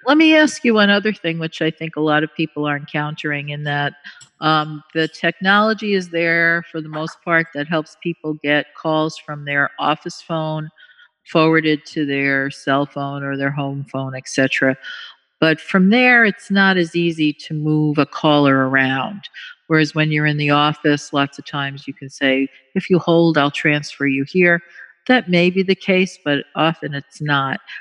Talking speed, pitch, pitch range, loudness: 190 wpm, 155 Hz, 145-170 Hz, -17 LUFS